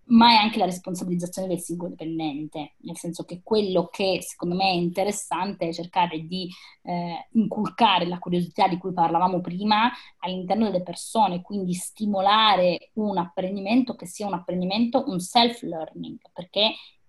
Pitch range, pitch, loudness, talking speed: 175-210 Hz, 185 Hz, -24 LUFS, 150 wpm